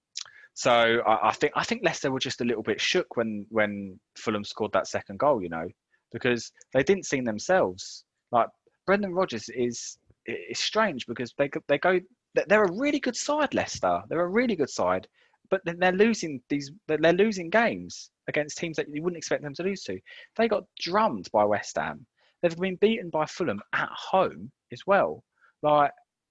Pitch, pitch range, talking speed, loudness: 165 Hz, 125-205 Hz, 185 wpm, -27 LUFS